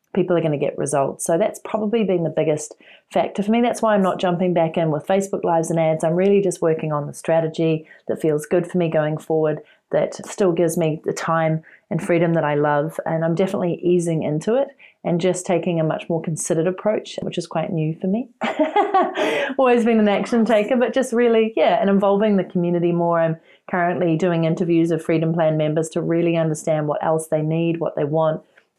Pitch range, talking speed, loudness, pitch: 160-200 Hz, 215 wpm, -20 LUFS, 170 Hz